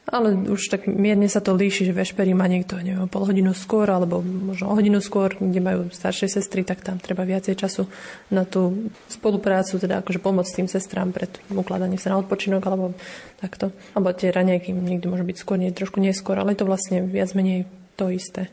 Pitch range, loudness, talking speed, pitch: 185-195 Hz, -23 LUFS, 200 wpm, 190 Hz